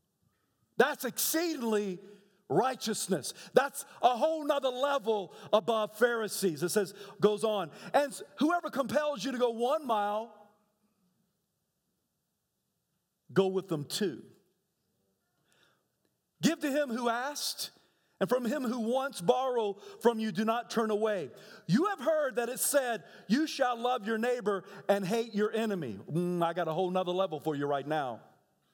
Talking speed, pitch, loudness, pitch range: 145 wpm, 225 Hz, -31 LUFS, 200-260 Hz